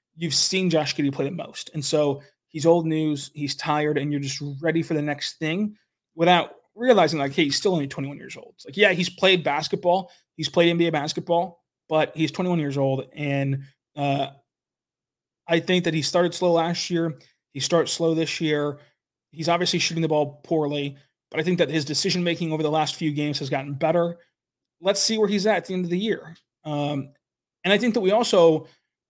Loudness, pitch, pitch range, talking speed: -23 LUFS, 160 Hz, 145-175 Hz, 210 wpm